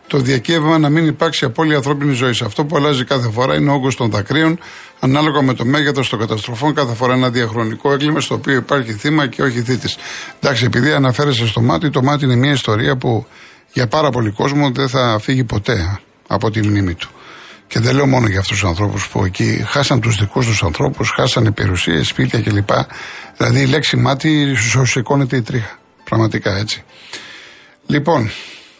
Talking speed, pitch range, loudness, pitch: 190 wpm, 110-145 Hz, -15 LUFS, 130 Hz